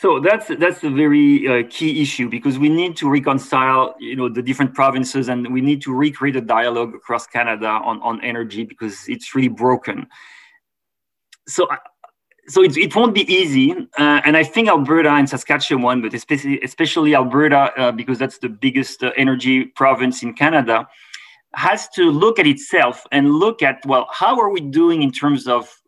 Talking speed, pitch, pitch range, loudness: 180 wpm, 140 Hz, 125-155 Hz, -16 LUFS